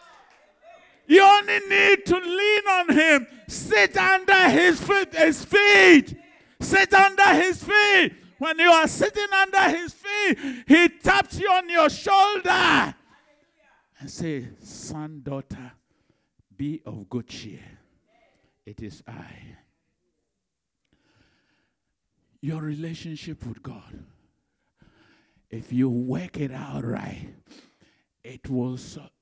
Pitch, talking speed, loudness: 320 Hz, 110 wpm, -19 LUFS